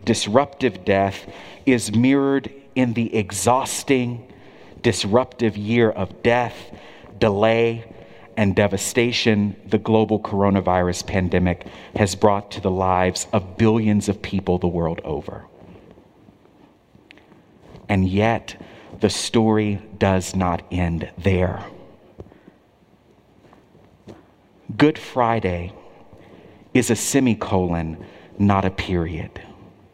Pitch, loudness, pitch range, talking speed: 100 Hz, -20 LUFS, 95-115 Hz, 90 wpm